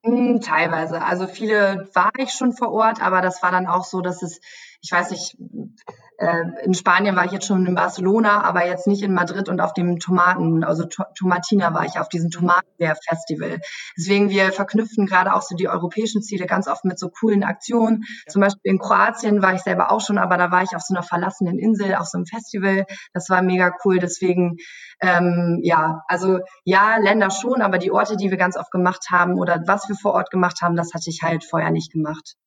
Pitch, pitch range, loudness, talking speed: 185 Hz, 175-205 Hz, -19 LUFS, 215 wpm